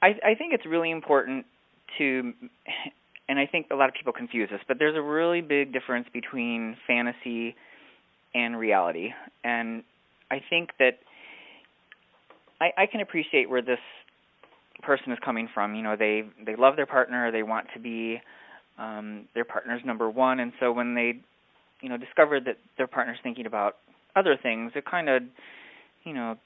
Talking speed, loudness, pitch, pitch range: 170 wpm, -27 LUFS, 125 Hz, 115-145 Hz